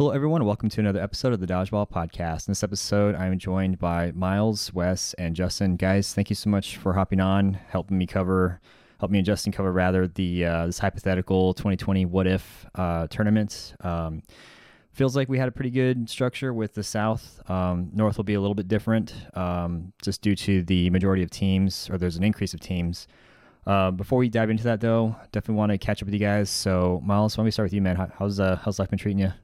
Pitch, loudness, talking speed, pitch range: 100 Hz, -25 LUFS, 230 wpm, 90-105 Hz